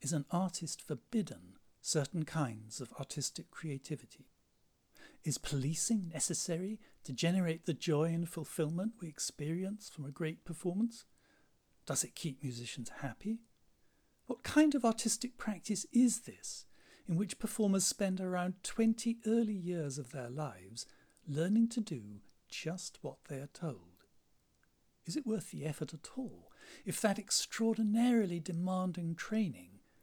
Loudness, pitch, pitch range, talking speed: -37 LUFS, 170 Hz, 145-215 Hz, 135 wpm